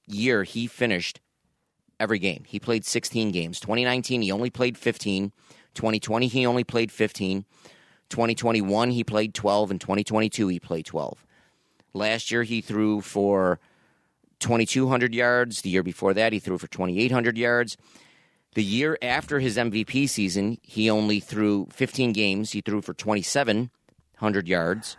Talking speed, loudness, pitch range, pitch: 145 wpm, -25 LUFS, 100-120 Hz, 110 Hz